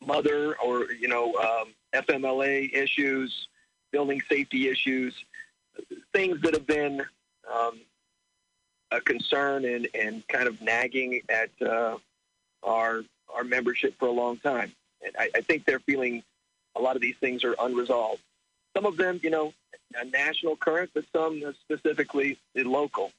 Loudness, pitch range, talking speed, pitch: -27 LUFS, 120-150 Hz, 145 wpm, 135 Hz